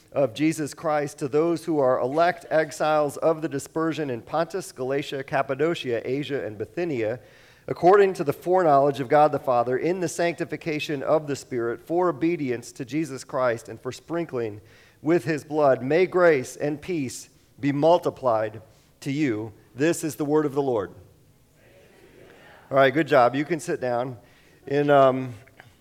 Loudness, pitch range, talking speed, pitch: -24 LUFS, 130-160 Hz, 160 wpm, 145 Hz